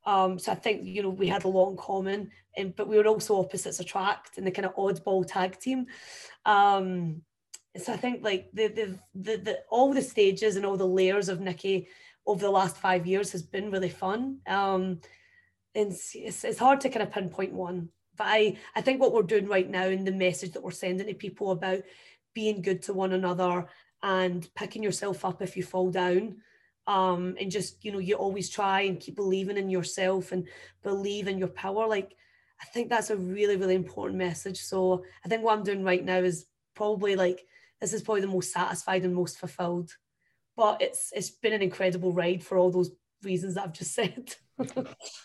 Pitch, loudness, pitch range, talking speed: 190 Hz, -29 LUFS, 185-205 Hz, 210 wpm